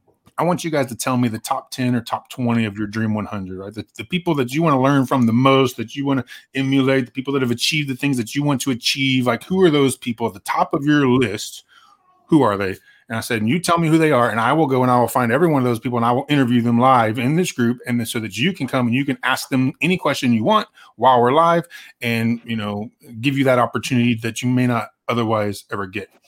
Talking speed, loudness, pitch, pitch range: 285 wpm, -19 LUFS, 130 Hz, 120-145 Hz